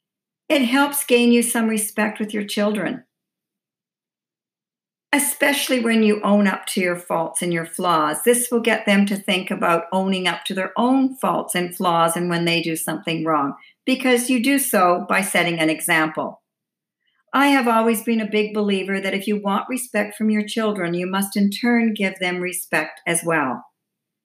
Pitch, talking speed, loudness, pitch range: 205 Hz, 180 wpm, -20 LUFS, 175-235 Hz